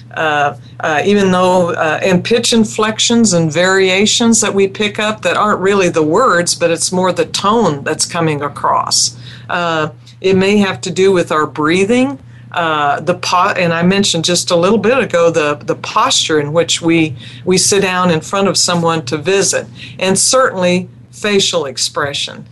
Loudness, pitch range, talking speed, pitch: -13 LUFS, 155-195 Hz, 175 wpm, 175 Hz